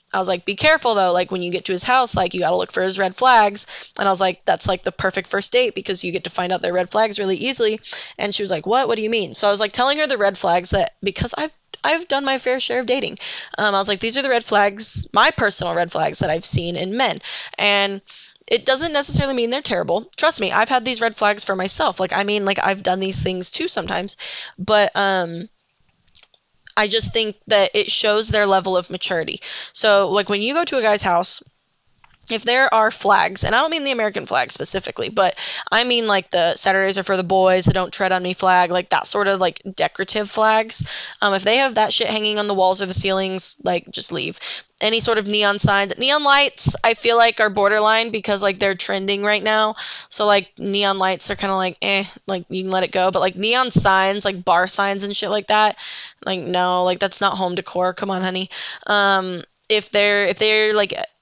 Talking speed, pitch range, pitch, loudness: 240 wpm, 185-220 Hz, 200 Hz, -18 LUFS